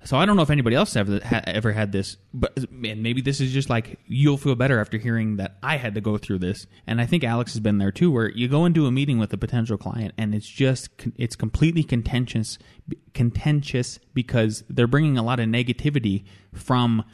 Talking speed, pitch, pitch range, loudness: 225 wpm, 120 Hz, 110-135 Hz, -23 LUFS